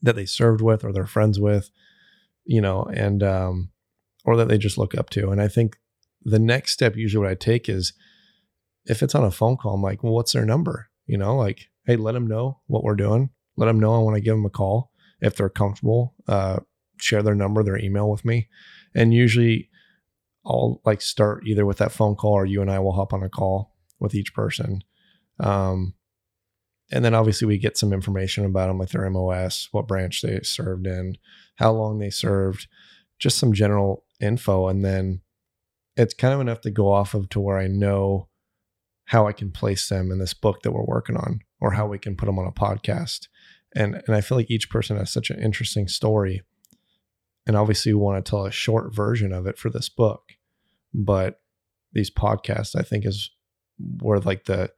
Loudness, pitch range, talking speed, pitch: -23 LUFS, 95-110 Hz, 210 wpm, 105 Hz